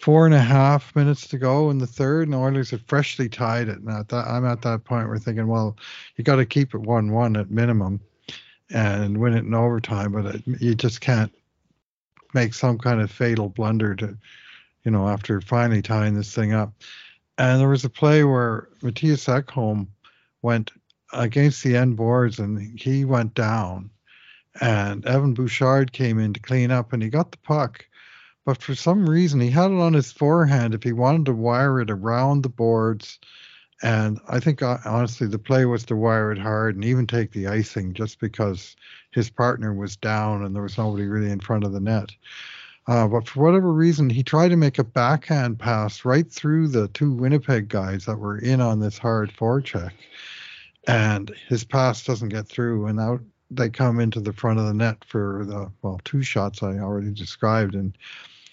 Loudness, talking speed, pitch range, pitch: -22 LUFS, 195 wpm, 110-130 Hz, 115 Hz